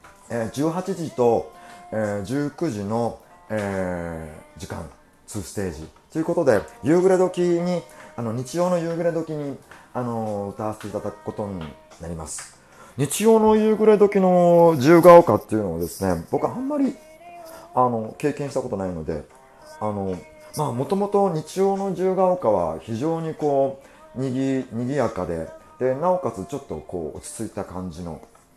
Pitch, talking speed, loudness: 135 Hz, 295 characters per minute, -22 LUFS